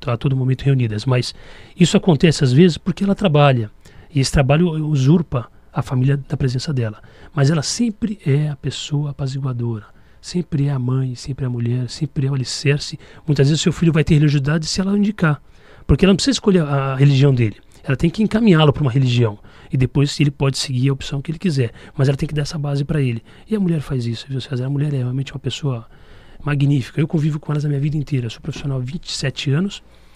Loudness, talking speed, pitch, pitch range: -18 LUFS, 225 wpm, 140 Hz, 130-155 Hz